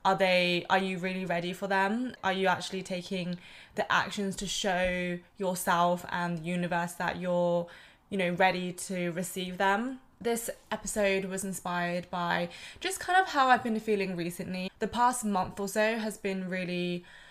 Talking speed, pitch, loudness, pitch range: 170 wpm, 185 Hz, -30 LUFS, 180-200 Hz